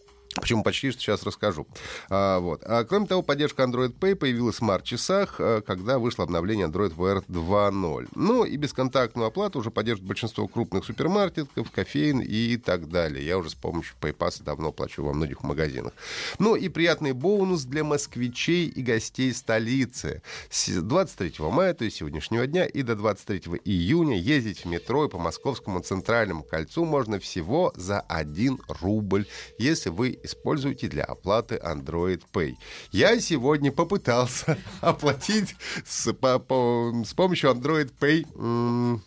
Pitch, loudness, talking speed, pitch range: 120 Hz, -26 LUFS, 150 wpm, 100-145 Hz